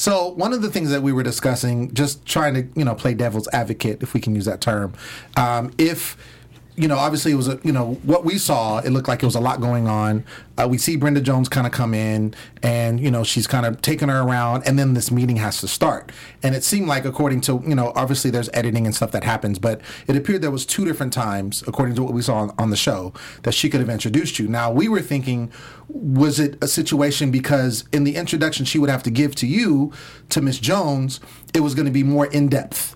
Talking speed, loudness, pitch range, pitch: 250 wpm, -20 LUFS, 120-145 Hz, 130 Hz